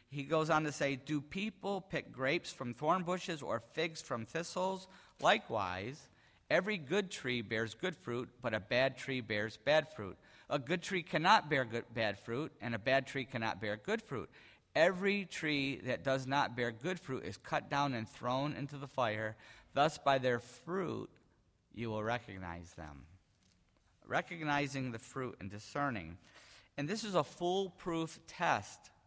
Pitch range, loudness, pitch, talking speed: 115-165 Hz, -37 LUFS, 135 Hz, 165 wpm